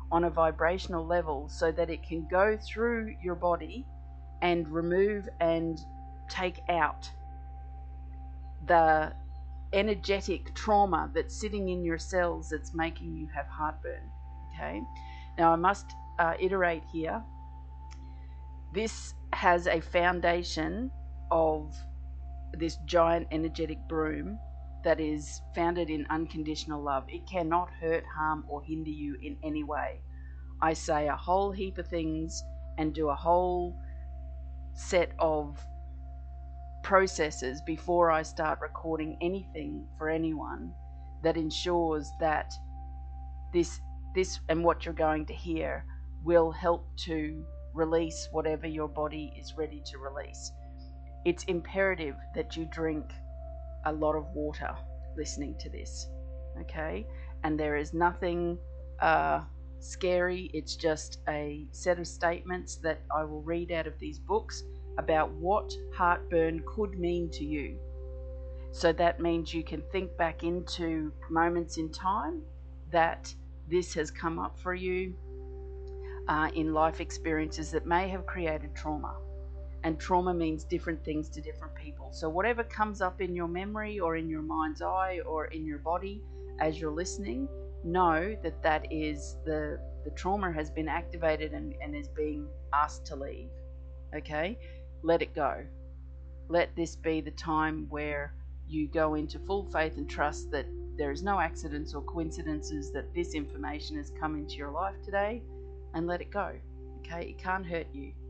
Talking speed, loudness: 145 wpm, -32 LUFS